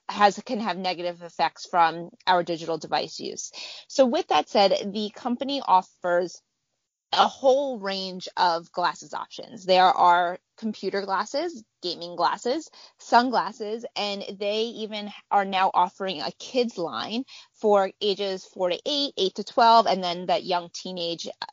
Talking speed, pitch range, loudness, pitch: 145 wpm, 180-230 Hz, -25 LUFS, 195 Hz